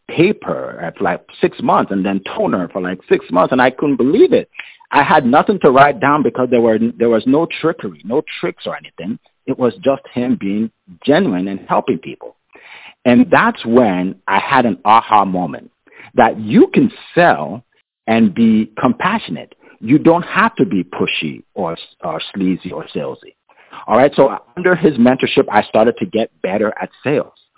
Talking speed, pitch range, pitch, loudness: 180 wpm, 100-140 Hz, 115 Hz, -15 LUFS